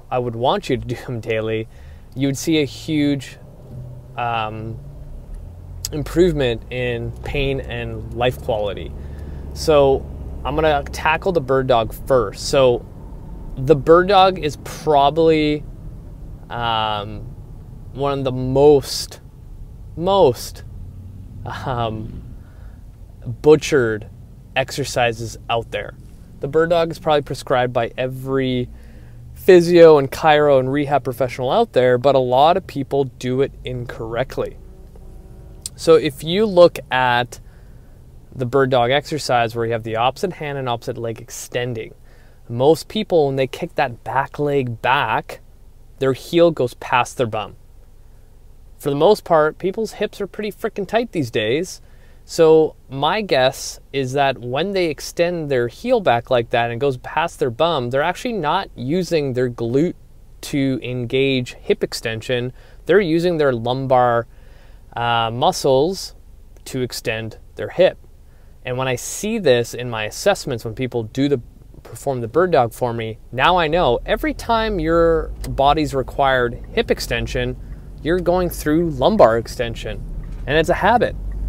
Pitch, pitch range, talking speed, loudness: 130 Hz, 115-150 Hz, 140 wpm, -19 LUFS